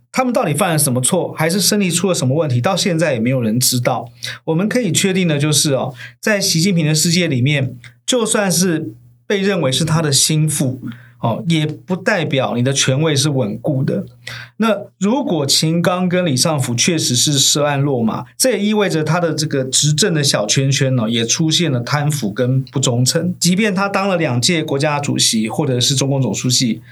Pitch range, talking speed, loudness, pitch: 130-175 Hz, 295 characters per minute, -15 LUFS, 150 Hz